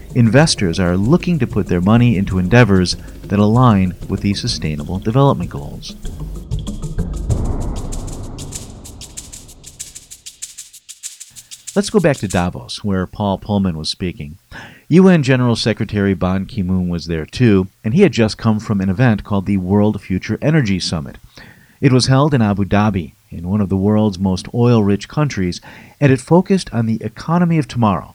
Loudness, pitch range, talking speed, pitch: -16 LUFS, 95-125 Hz, 155 wpm, 105 Hz